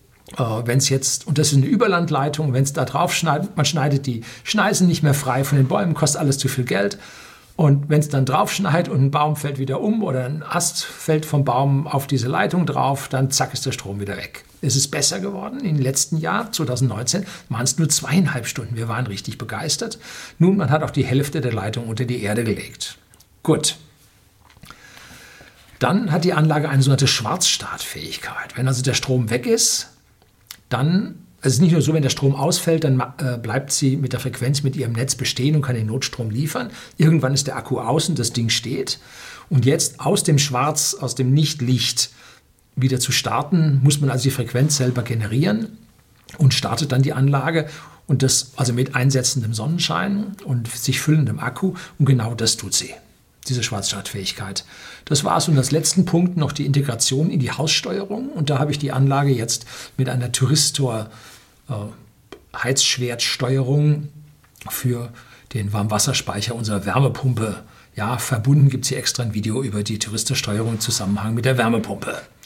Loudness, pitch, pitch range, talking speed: -20 LUFS, 135 Hz, 125-150 Hz, 180 wpm